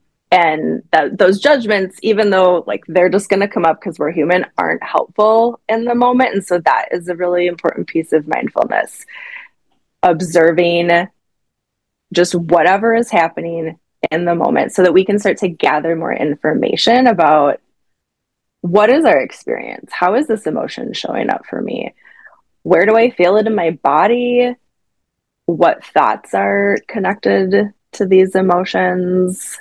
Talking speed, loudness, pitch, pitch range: 150 wpm, -14 LUFS, 180 Hz, 170-215 Hz